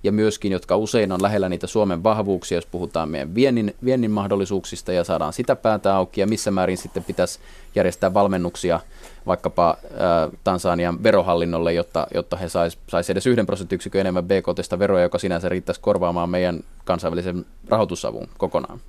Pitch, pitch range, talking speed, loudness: 95 Hz, 85-100 Hz, 155 wpm, -22 LUFS